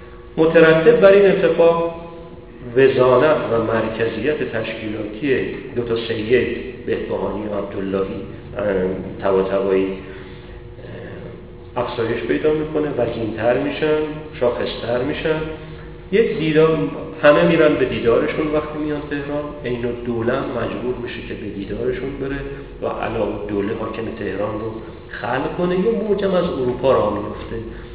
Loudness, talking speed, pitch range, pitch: -19 LUFS, 115 wpm, 110-155 Hz, 120 Hz